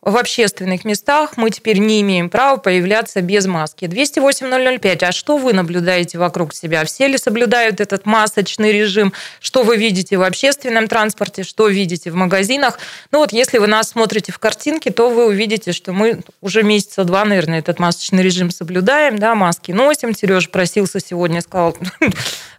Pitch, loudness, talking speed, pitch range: 205 Hz, -15 LUFS, 165 wpm, 180-230 Hz